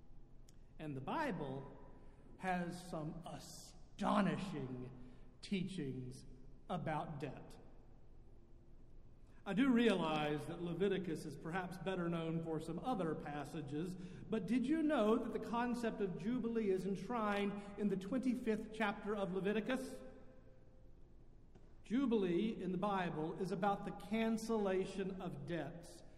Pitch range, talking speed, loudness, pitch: 150-210 Hz, 110 wpm, -41 LUFS, 180 Hz